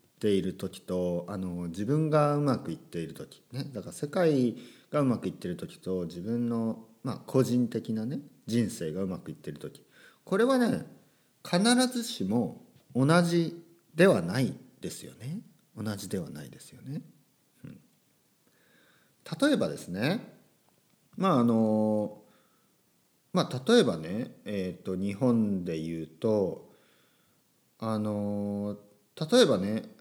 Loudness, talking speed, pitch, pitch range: -29 LUFS, 240 characters per minute, 110 Hz, 100-150 Hz